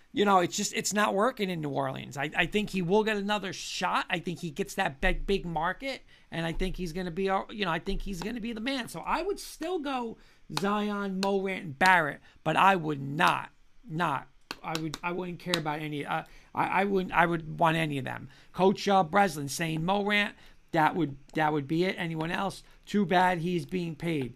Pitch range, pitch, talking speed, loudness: 160-200 Hz, 185 Hz, 230 wpm, -29 LUFS